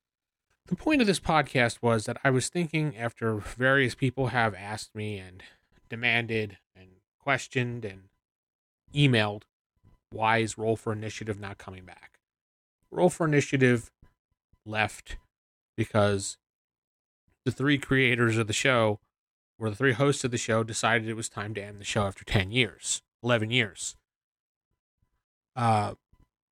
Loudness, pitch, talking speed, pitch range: -27 LUFS, 110 Hz, 140 wpm, 100-125 Hz